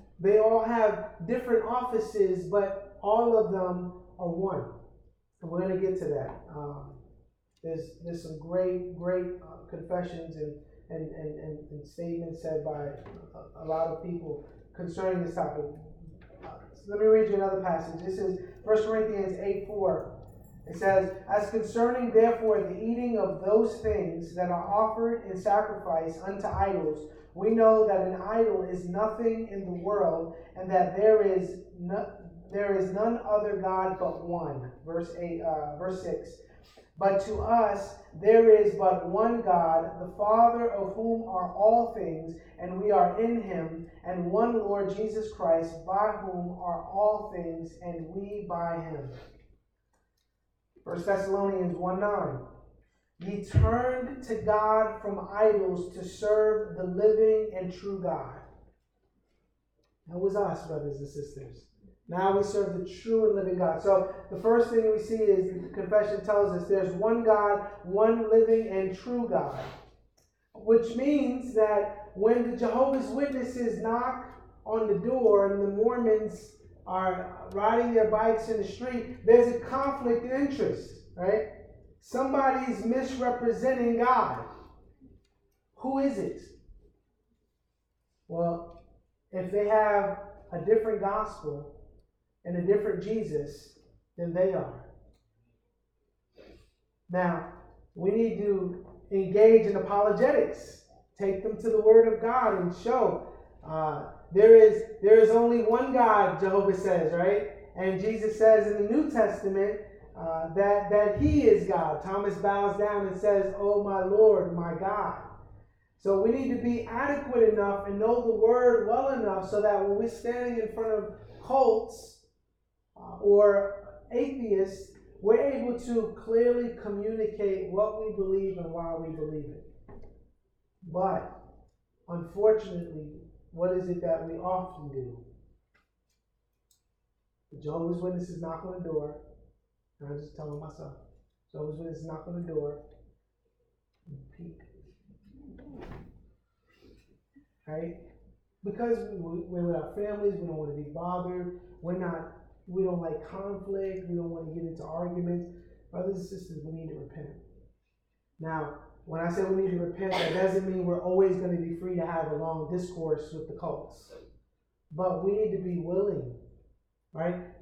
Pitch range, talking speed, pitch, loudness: 170-215 Hz, 150 wpm, 195 Hz, -27 LUFS